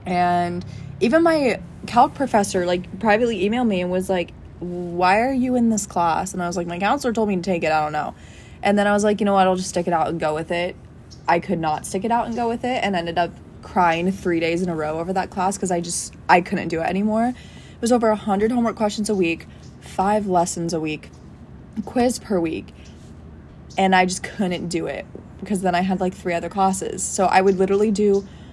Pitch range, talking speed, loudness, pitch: 175-210 Hz, 240 wpm, -21 LUFS, 185 Hz